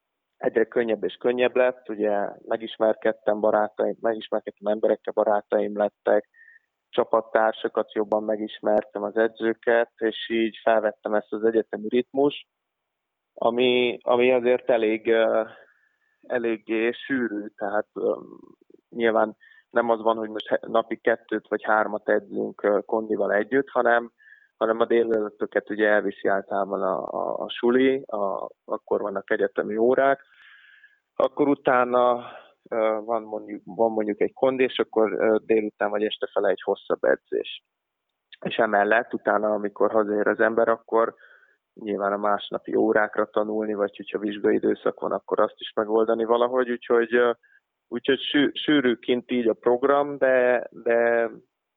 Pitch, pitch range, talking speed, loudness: 115 Hz, 105-125 Hz, 125 wpm, -24 LUFS